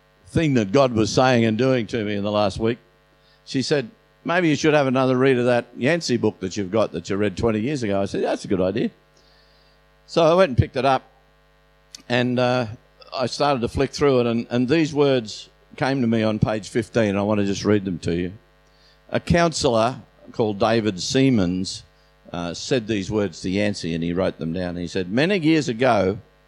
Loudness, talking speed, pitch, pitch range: -21 LUFS, 215 wpm, 115 Hz, 100-130 Hz